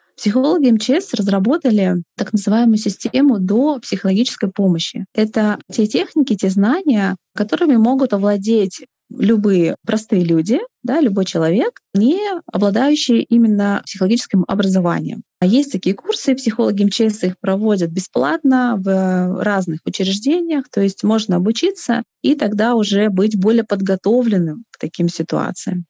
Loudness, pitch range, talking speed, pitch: -16 LUFS, 195-245 Hz, 125 wpm, 215 Hz